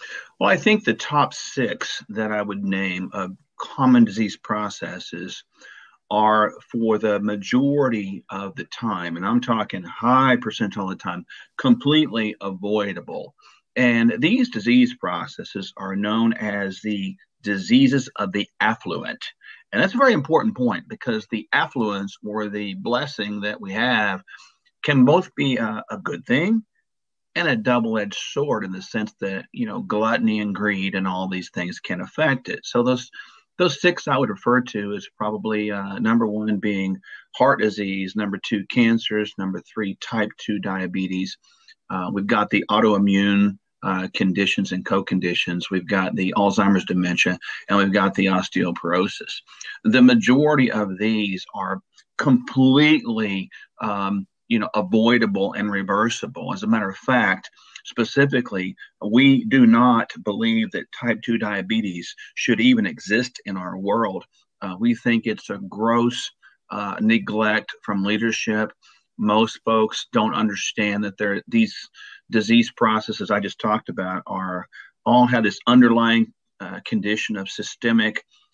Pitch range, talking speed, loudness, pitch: 100-130 Hz, 145 wpm, -21 LUFS, 110 Hz